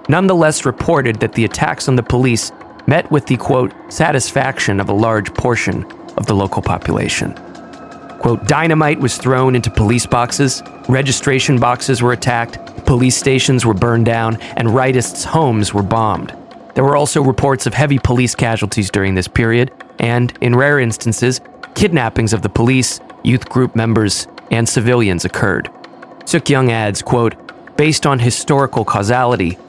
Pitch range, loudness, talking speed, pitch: 110-135 Hz, -14 LUFS, 150 wpm, 120 Hz